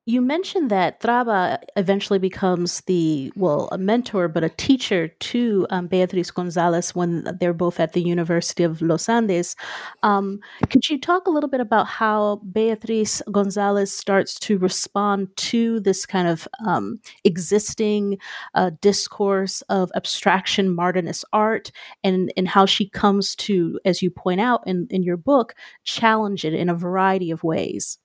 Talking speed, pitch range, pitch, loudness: 155 wpm, 180-215 Hz, 195 Hz, -21 LUFS